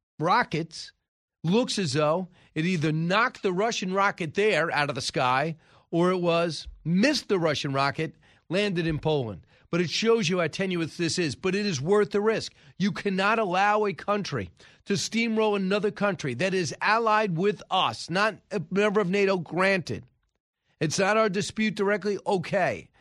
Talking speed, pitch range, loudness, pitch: 170 wpm, 160-205 Hz, -26 LUFS, 190 Hz